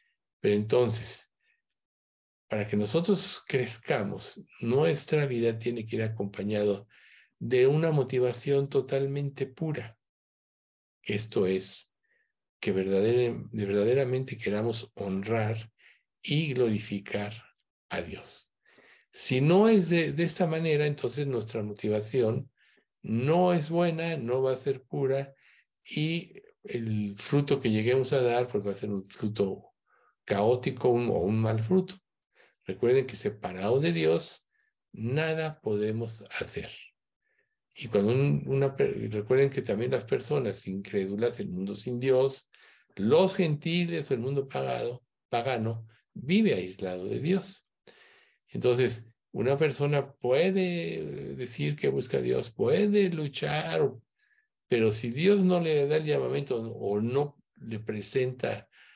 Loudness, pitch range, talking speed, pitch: -29 LUFS, 110-150 Hz, 120 wpm, 125 Hz